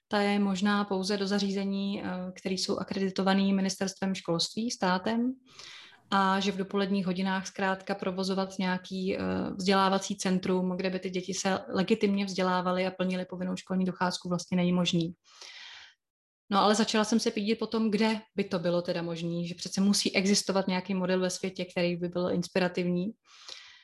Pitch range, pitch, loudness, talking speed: 185-200 Hz, 190 Hz, -29 LUFS, 155 wpm